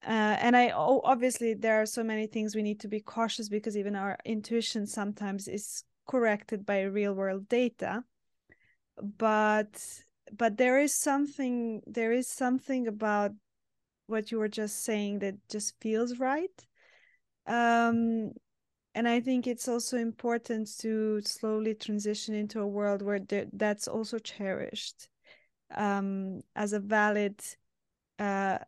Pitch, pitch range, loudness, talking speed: 220 Hz, 210-235 Hz, -31 LUFS, 140 wpm